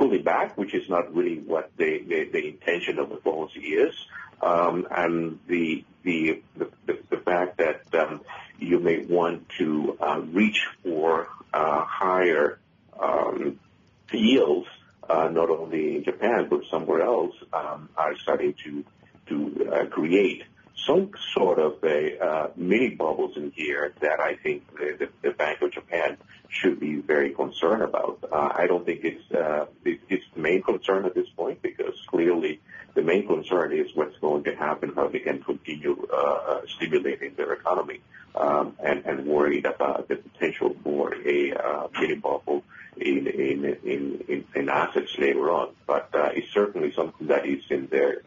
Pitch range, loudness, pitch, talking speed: 360-420 Hz, -26 LUFS, 385 Hz, 165 wpm